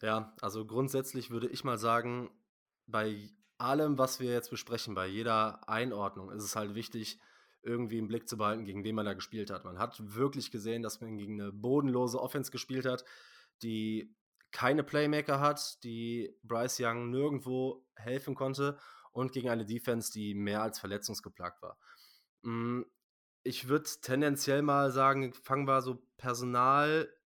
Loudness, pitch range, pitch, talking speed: -34 LUFS, 110-130 Hz, 120 Hz, 155 wpm